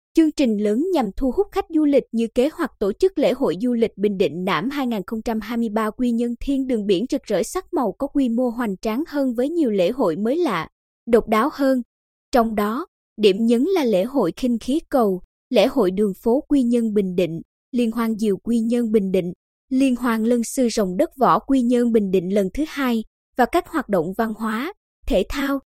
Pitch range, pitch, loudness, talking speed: 220-275 Hz, 240 Hz, -21 LUFS, 215 wpm